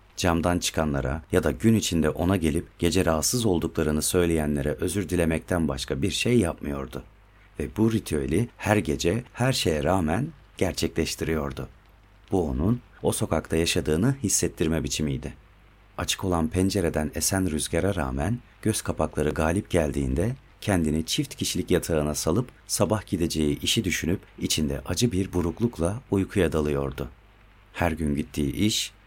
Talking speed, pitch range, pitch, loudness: 130 wpm, 80-100 Hz, 90 Hz, -26 LUFS